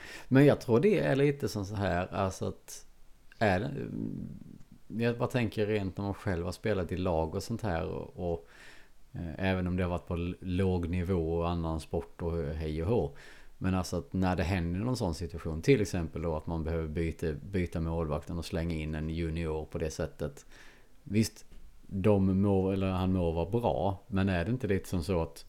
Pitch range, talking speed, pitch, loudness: 85-100 Hz, 205 wpm, 90 Hz, -32 LUFS